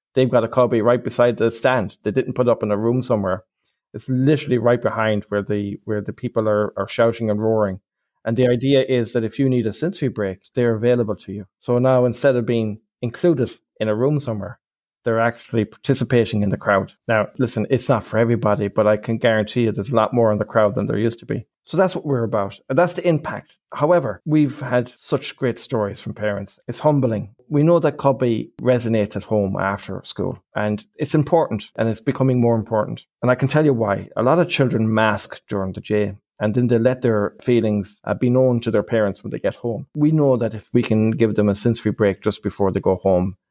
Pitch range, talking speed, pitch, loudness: 105-130 Hz, 225 wpm, 115 Hz, -20 LUFS